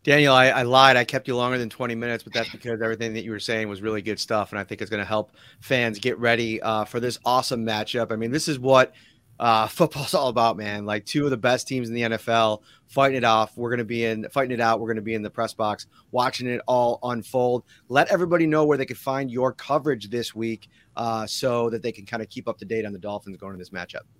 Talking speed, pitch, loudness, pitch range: 270 wpm, 115 Hz, -23 LUFS, 110-125 Hz